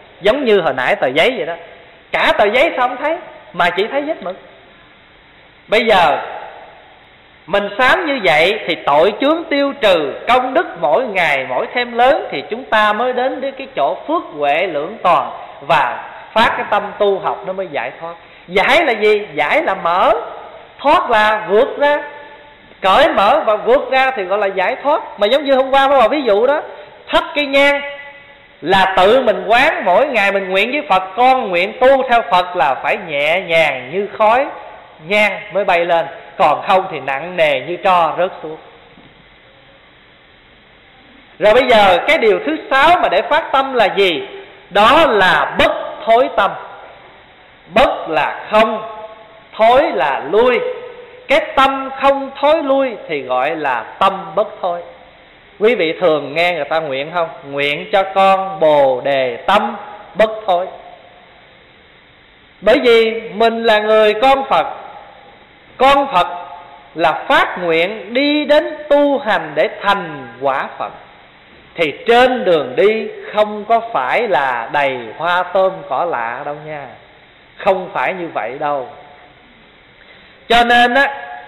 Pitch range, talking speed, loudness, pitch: 185-275 Hz, 160 wpm, -14 LUFS, 220 Hz